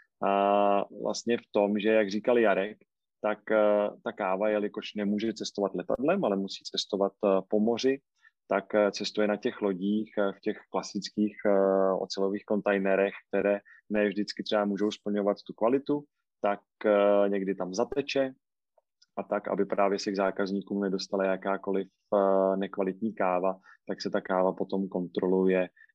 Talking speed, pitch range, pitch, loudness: 155 wpm, 95-105 Hz, 100 Hz, -29 LUFS